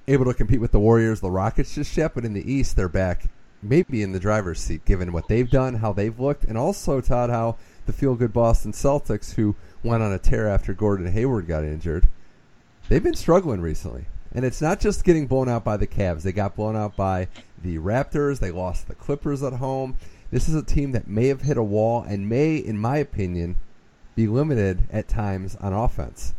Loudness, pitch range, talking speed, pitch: -24 LUFS, 95-130 Hz, 215 wpm, 110 Hz